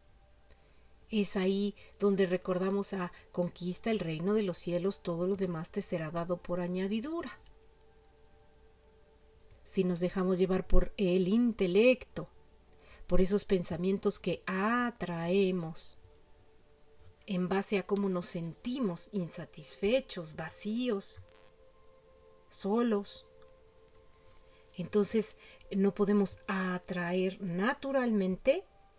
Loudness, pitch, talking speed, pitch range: -33 LUFS, 185 Hz, 95 wpm, 170-205 Hz